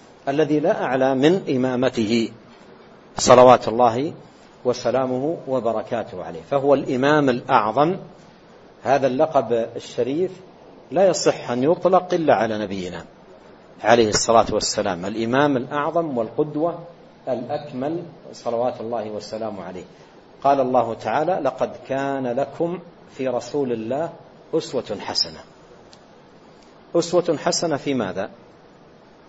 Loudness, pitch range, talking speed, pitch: -21 LUFS, 115-155 Hz, 100 wpm, 135 Hz